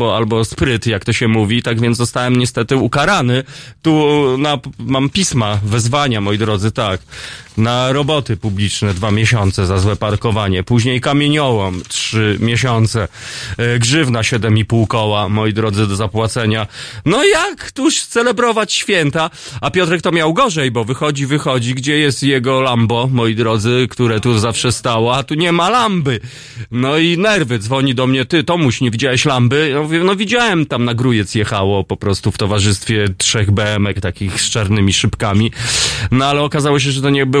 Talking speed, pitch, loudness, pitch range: 170 wpm, 120 Hz, -14 LUFS, 110-140 Hz